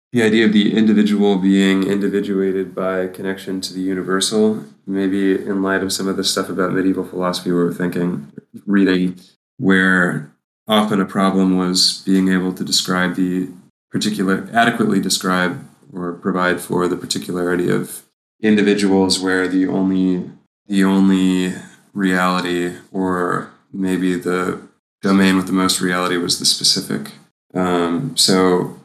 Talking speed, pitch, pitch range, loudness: 135 wpm, 95 Hz, 90-95 Hz, -17 LUFS